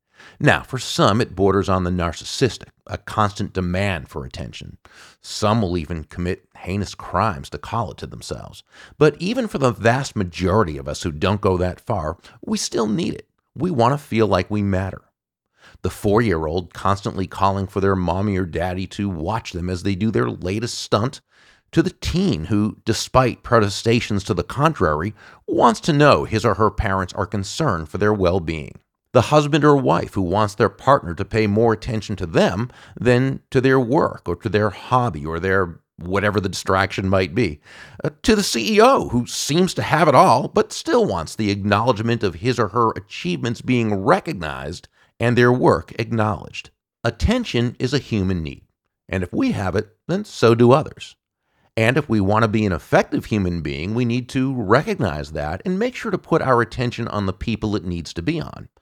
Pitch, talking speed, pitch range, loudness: 105 Hz, 195 wpm, 95-125 Hz, -20 LUFS